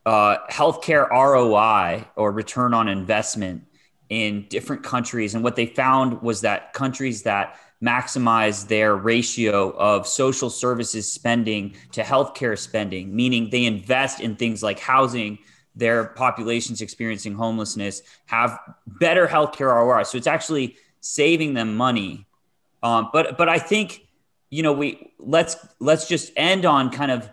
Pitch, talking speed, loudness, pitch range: 115 Hz, 140 wpm, -21 LUFS, 110-130 Hz